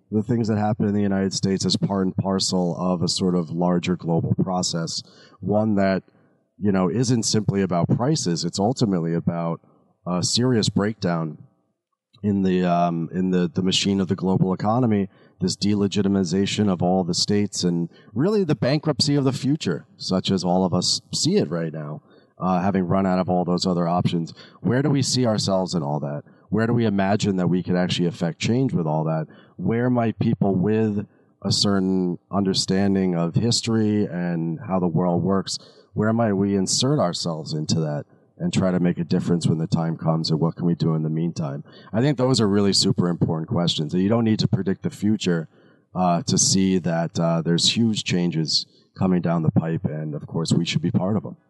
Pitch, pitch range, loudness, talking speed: 95 Hz, 85-105 Hz, -22 LUFS, 200 wpm